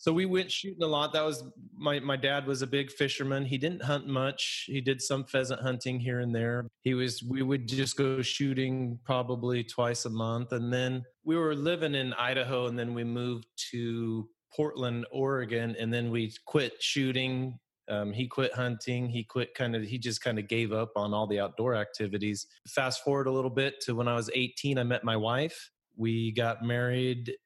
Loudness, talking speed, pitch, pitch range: -31 LUFS, 205 wpm, 125 Hz, 120-135 Hz